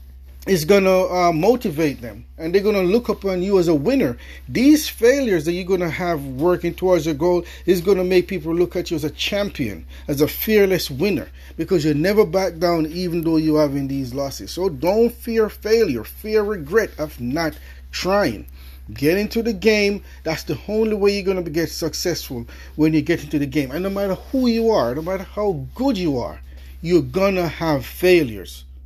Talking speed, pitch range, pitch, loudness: 205 wpm, 150-200 Hz, 175 Hz, -20 LUFS